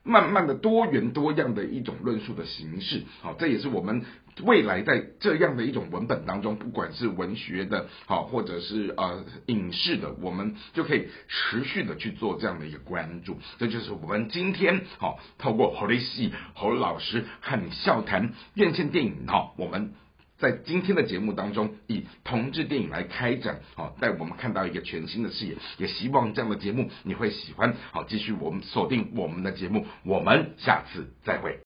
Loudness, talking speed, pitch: -28 LUFS, 290 characters per minute, 115 Hz